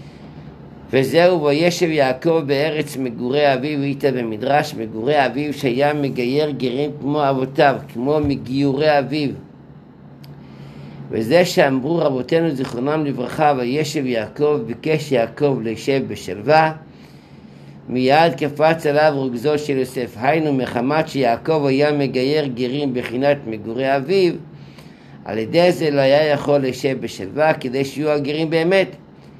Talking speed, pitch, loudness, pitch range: 115 wpm, 140 Hz, -18 LUFS, 125-150 Hz